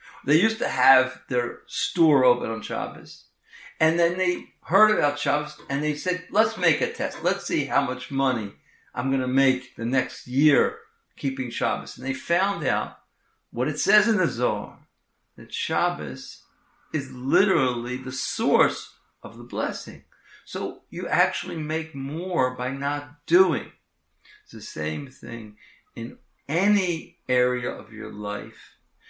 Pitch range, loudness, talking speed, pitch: 125-170 Hz, -24 LUFS, 150 wpm, 140 Hz